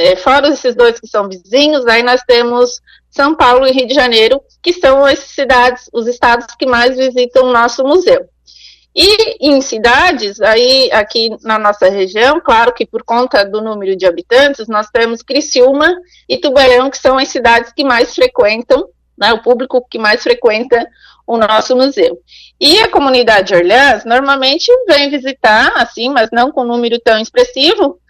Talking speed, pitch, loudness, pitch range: 170 wpm, 255 Hz, -10 LUFS, 235-285 Hz